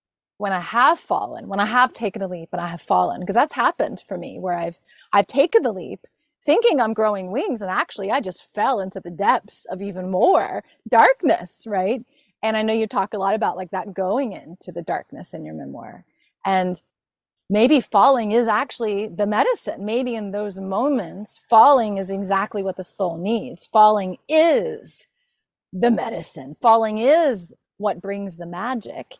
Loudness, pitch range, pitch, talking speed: -21 LUFS, 190-240 Hz, 205 Hz, 180 wpm